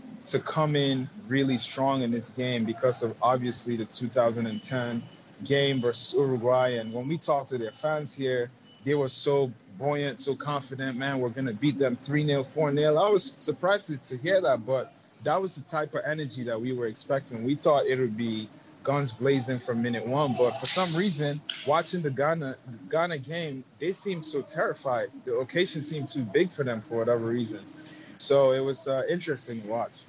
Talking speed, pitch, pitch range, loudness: 195 wpm, 135 Hz, 125-150 Hz, -28 LUFS